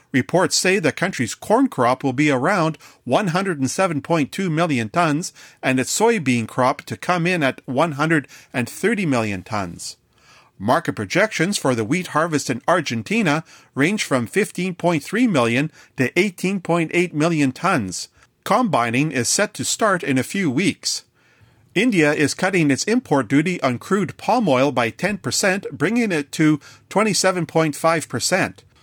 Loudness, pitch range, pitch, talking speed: -20 LUFS, 130-180 Hz, 155 Hz, 135 wpm